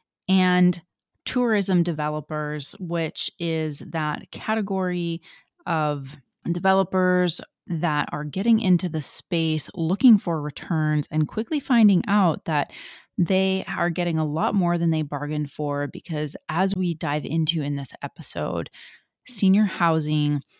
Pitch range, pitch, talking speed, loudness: 150-190 Hz, 170 Hz, 125 wpm, -24 LUFS